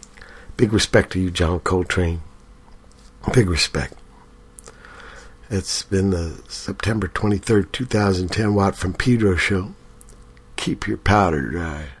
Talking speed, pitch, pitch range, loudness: 110 wpm, 90 Hz, 80-100 Hz, -21 LUFS